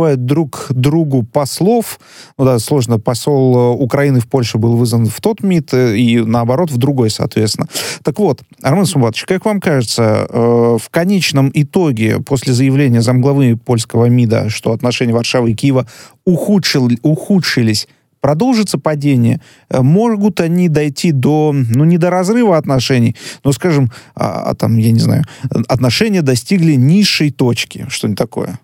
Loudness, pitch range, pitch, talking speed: -13 LUFS, 120-160 Hz, 135 Hz, 140 wpm